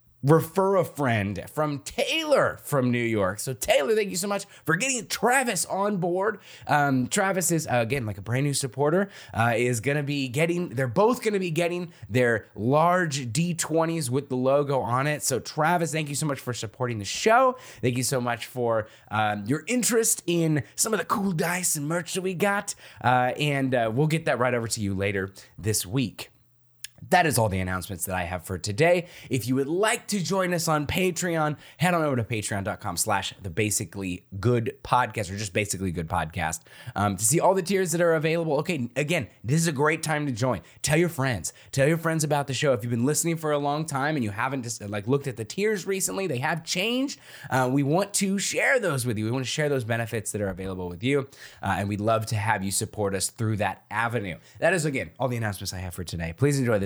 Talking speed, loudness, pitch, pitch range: 230 wpm, -25 LUFS, 135 Hz, 110-165 Hz